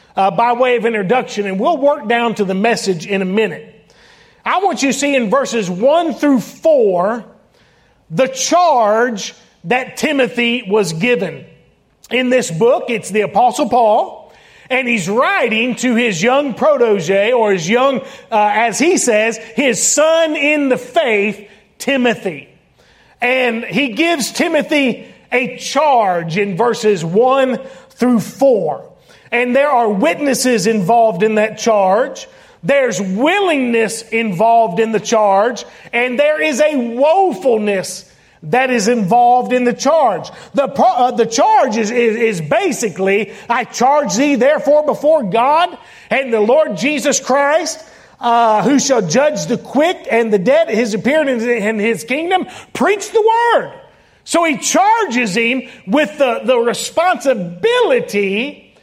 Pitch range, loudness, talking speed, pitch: 220-285 Hz, -14 LUFS, 140 wpm, 245 Hz